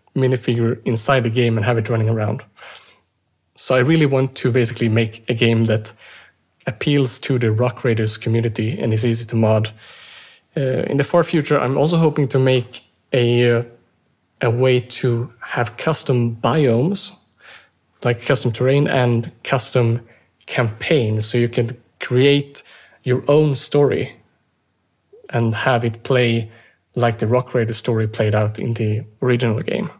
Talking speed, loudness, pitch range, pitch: 150 wpm, -19 LUFS, 115-130 Hz, 120 Hz